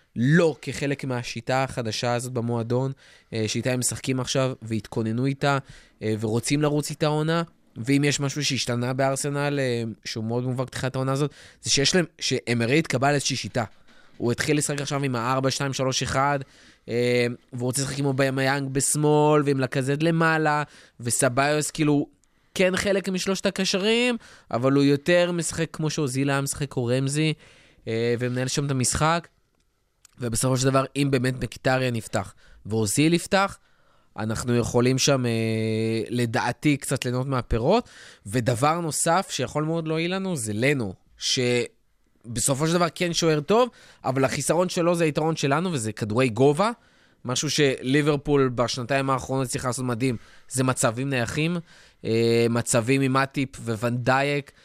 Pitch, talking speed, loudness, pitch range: 135 Hz, 140 wpm, -24 LUFS, 120-150 Hz